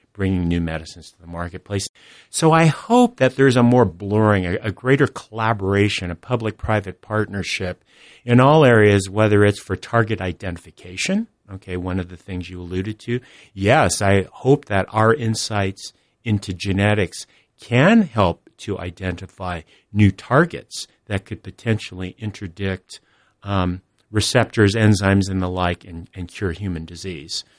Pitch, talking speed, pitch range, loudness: 100 Hz, 145 wpm, 90-110 Hz, -19 LUFS